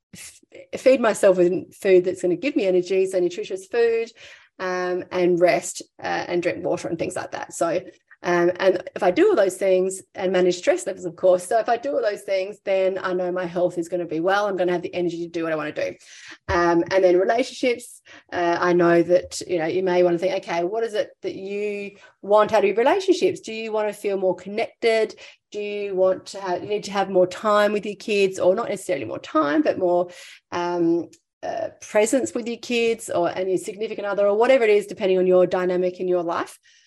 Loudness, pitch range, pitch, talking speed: -22 LUFS, 180-220 Hz, 190 Hz, 235 wpm